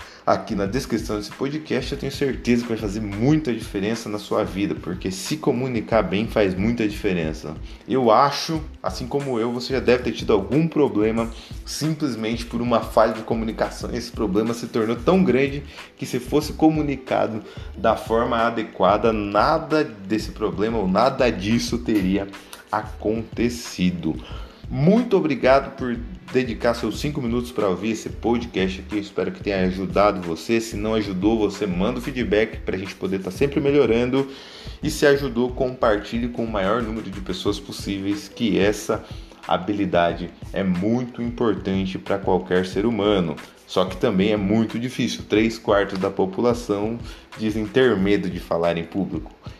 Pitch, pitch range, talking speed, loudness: 110 Hz, 100-125 Hz, 160 wpm, -22 LUFS